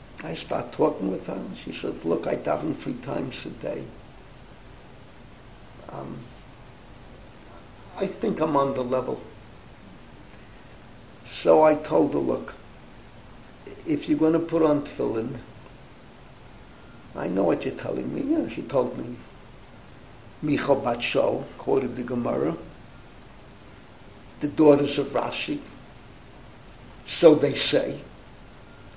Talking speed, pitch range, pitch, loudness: 115 wpm, 125-155 Hz, 145 Hz, -25 LUFS